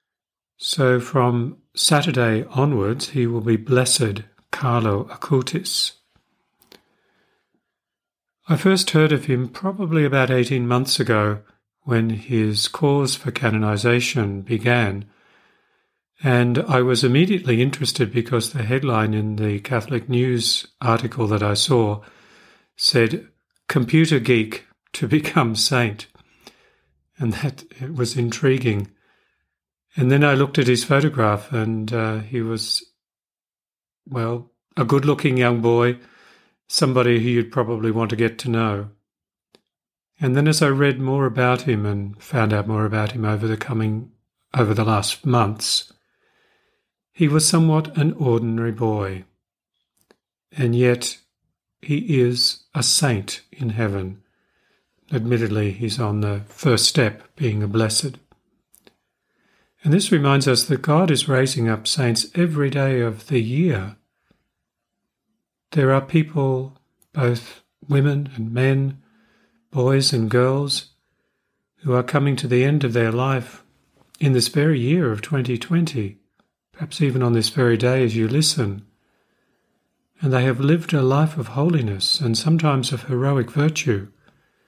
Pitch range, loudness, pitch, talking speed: 110-140 Hz, -20 LUFS, 125 Hz, 130 wpm